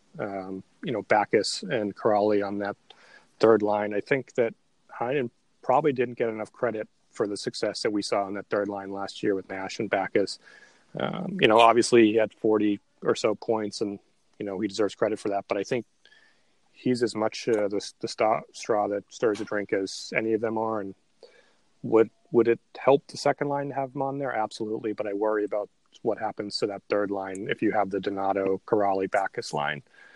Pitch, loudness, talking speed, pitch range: 105 Hz, -27 LUFS, 210 wpm, 100-115 Hz